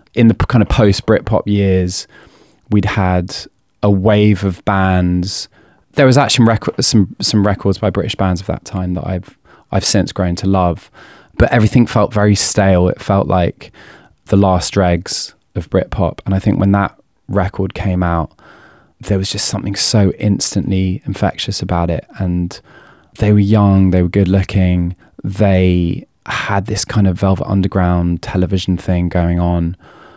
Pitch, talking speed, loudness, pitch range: 95 Hz, 160 wpm, -14 LUFS, 90-105 Hz